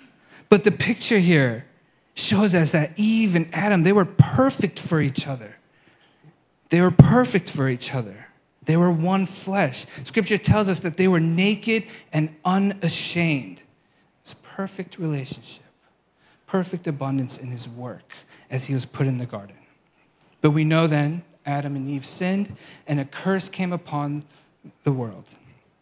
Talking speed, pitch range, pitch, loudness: 150 wpm, 140-190 Hz, 165 Hz, -22 LUFS